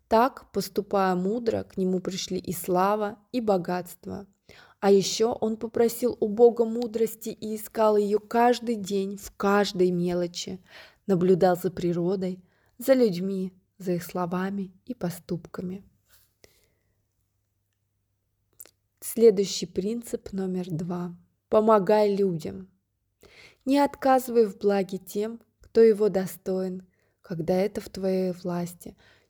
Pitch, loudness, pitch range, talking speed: 190 Hz, -26 LUFS, 180-215 Hz, 110 wpm